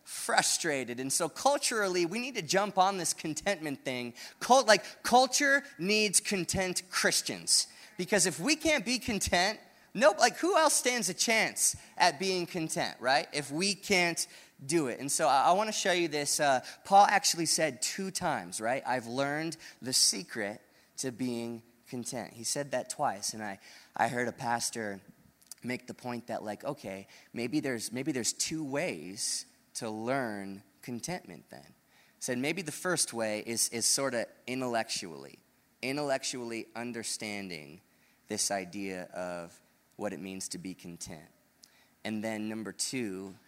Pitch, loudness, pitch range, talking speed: 140 Hz, -30 LUFS, 115-185 Hz, 160 wpm